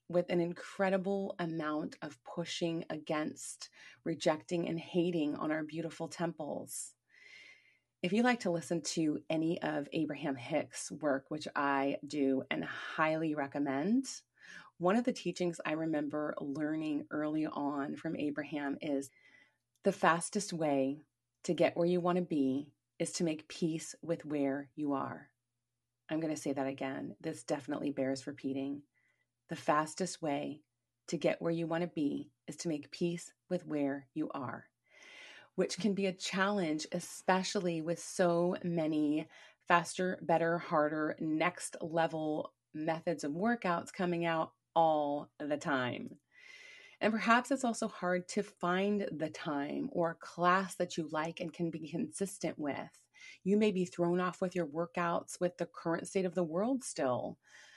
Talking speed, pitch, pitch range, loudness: 150 wpm, 165 Hz, 150-180 Hz, -35 LUFS